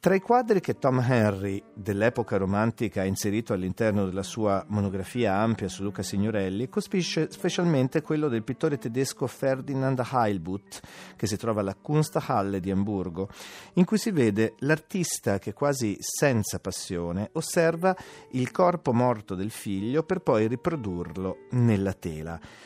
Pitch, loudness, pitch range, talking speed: 115 Hz, -27 LUFS, 100-145 Hz, 140 wpm